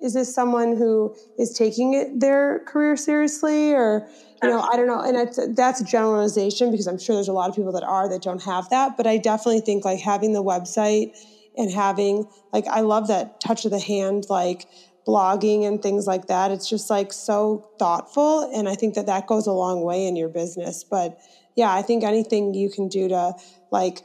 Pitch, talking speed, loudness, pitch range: 210 Hz, 215 wpm, -22 LUFS, 190-235 Hz